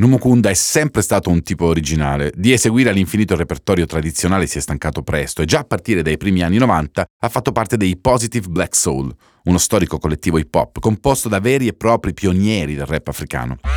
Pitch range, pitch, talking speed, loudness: 80-115 Hz, 90 Hz, 200 wpm, -17 LUFS